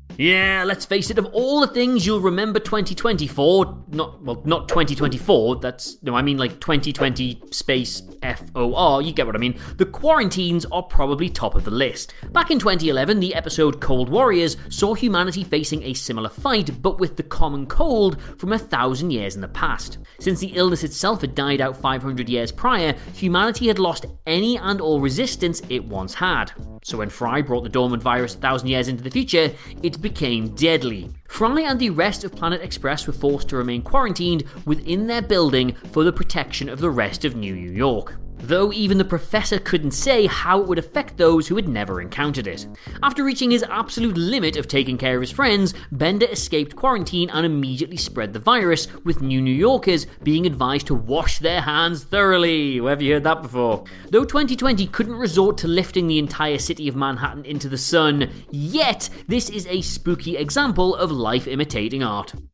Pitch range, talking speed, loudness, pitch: 130-190 Hz, 190 wpm, -21 LUFS, 160 Hz